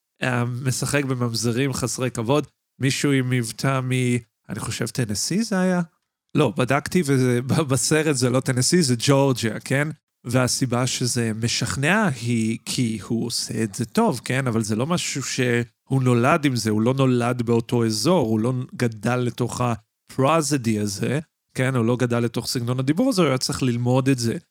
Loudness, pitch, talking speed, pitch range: -22 LUFS, 125 Hz, 160 wpm, 120-140 Hz